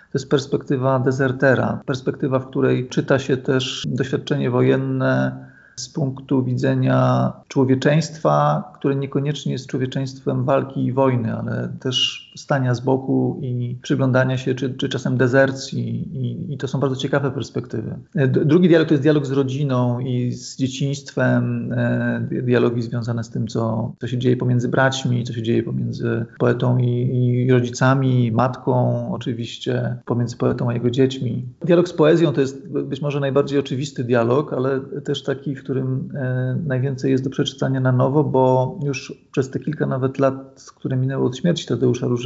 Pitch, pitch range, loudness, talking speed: 130 Hz, 125-140 Hz, -20 LUFS, 160 wpm